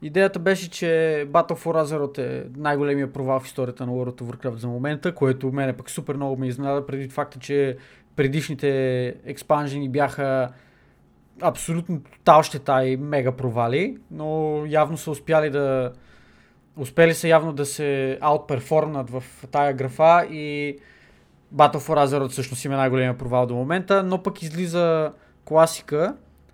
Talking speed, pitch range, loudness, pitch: 145 wpm, 130-155 Hz, -23 LUFS, 140 Hz